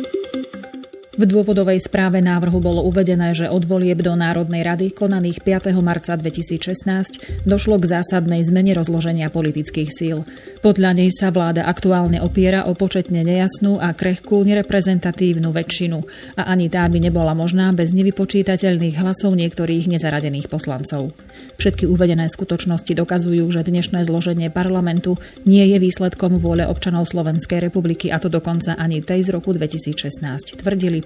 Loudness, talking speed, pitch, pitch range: -18 LUFS, 140 wpm, 175 Hz, 170-190 Hz